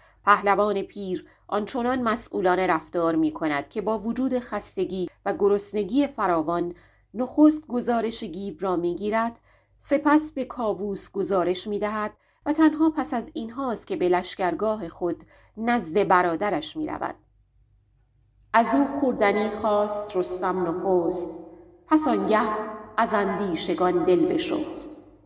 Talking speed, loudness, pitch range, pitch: 125 wpm, -25 LUFS, 180-240 Hz, 210 Hz